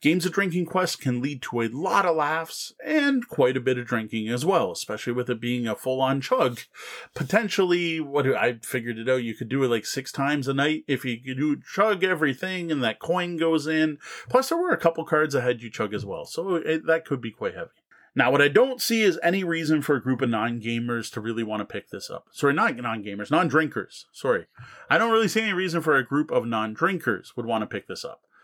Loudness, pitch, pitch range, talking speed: -25 LUFS, 145 Hz, 125-180 Hz, 235 wpm